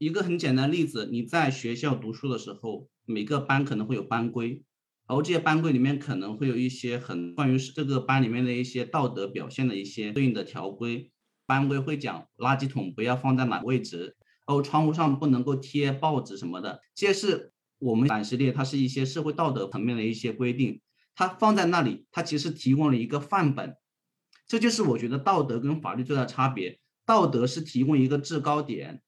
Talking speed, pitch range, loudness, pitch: 320 characters per minute, 125-150 Hz, -27 LUFS, 135 Hz